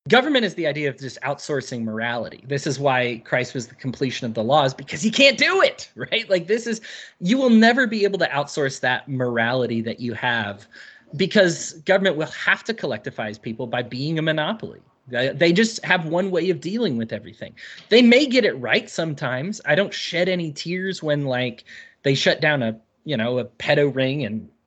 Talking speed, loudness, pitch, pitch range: 200 wpm, -21 LUFS, 145 Hz, 125-190 Hz